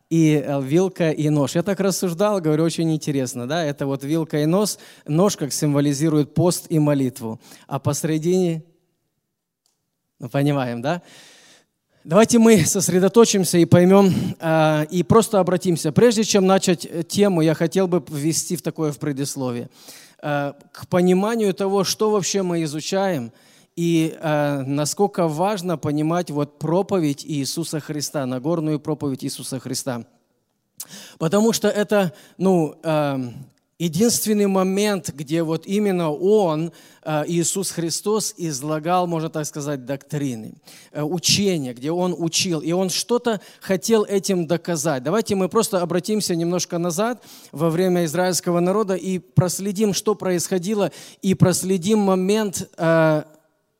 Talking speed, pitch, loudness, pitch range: 130 wpm, 170 Hz, -20 LUFS, 150-195 Hz